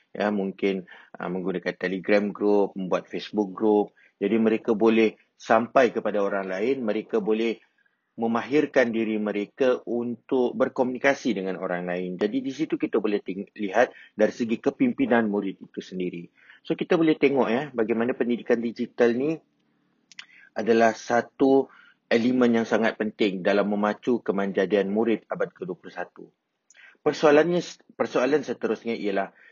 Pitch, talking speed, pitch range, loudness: 110 Hz, 130 wpm, 100-125 Hz, -25 LUFS